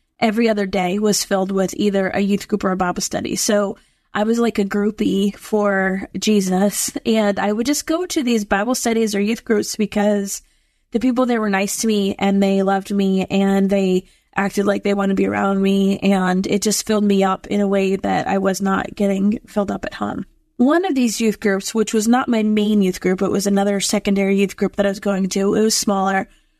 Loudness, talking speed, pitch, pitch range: -18 LUFS, 225 wpm, 200 Hz, 195-220 Hz